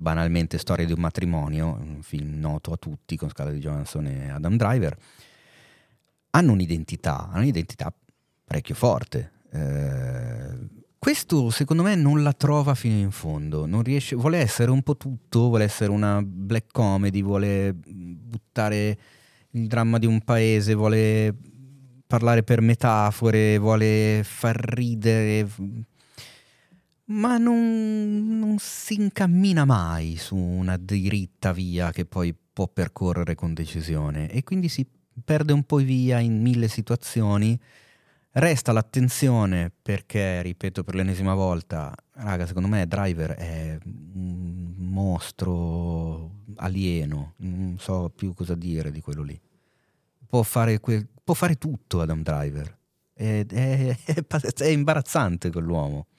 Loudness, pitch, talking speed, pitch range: -24 LUFS, 105 Hz, 130 wpm, 90-125 Hz